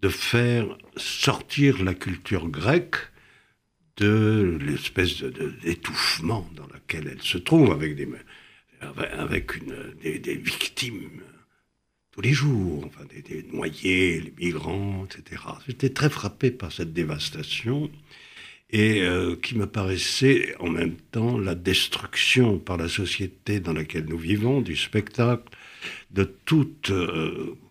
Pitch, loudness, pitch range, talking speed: 100 Hz, -25 LUFS, 85-120 Hz, 130 wpm